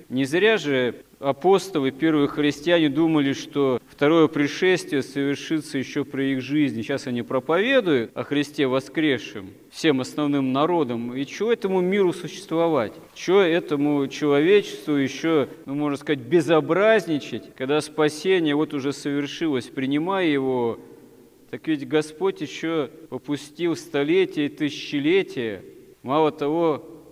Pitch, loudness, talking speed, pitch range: 150 Hz, -23 LUFS, 120 wpm, 140-170 Hz